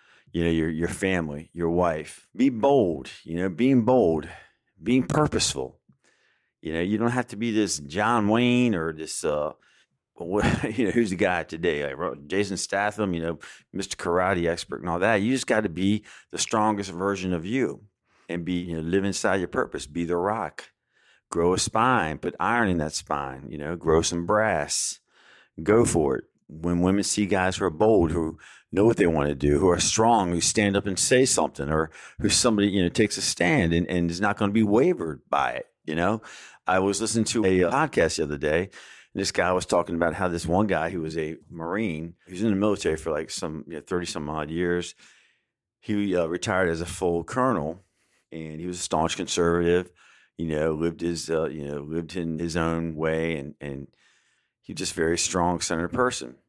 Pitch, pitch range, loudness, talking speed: 90 Hz, 80-105 Hz, -25 LUFS, 210 wpm